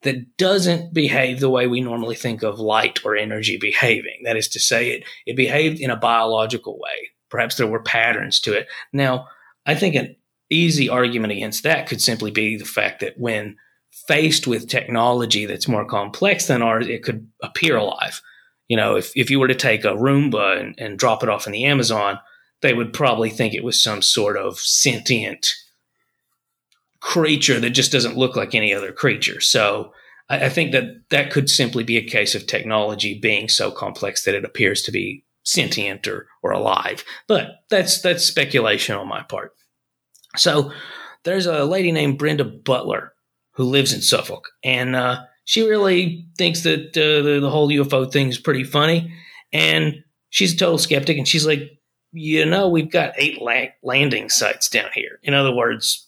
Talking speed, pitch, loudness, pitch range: 185 wpm, 135 Hz, -18 LUFS, 120-160 Hz